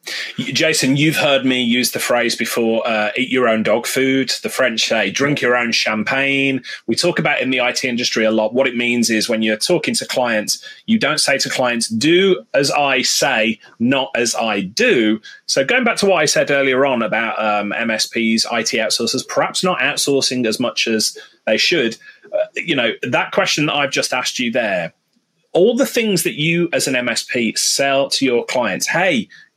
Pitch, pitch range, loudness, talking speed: 135 Hz, 115-180 Hz, -16 LUFS, 200 wpm